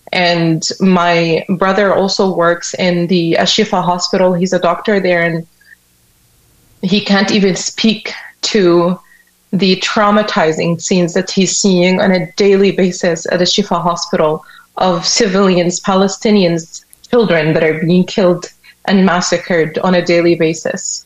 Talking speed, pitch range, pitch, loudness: 135 wpm, 170-195 Hz, 180 Hz, -12 LUFS